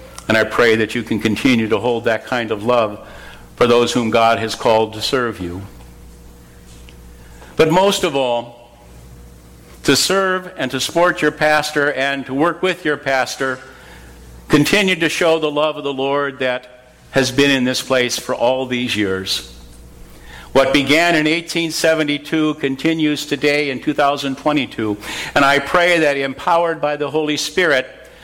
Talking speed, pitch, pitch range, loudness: 155 wpm, 130 Hz, 110-150 Hz, -16 LUFS